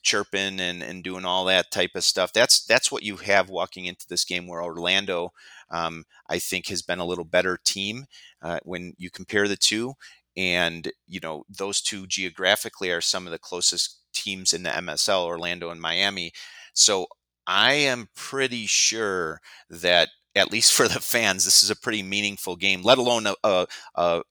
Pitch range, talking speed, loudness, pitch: 90-100 Hz, 185 wpm, -22 LUFS, 95 Hz